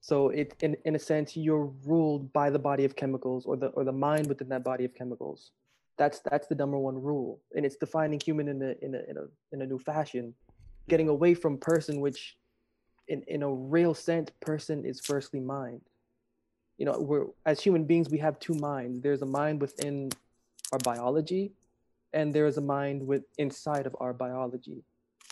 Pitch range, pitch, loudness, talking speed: 135-155 Hz, 145 Hz, -30 LUFS, 195 wpm